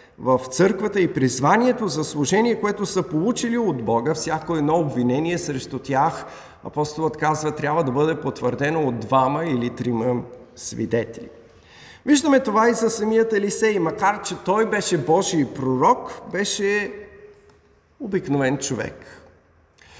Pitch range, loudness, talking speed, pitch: 130-205 Hz, -21 LUFS, 125 wpm, 160 Hz